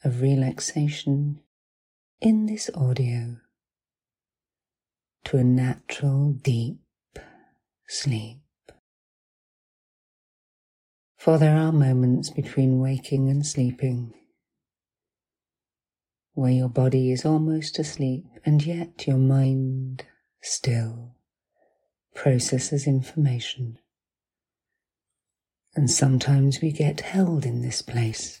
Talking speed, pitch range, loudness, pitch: 80 wpm, 125-150 Hz, -24 LUFS, 135 Hz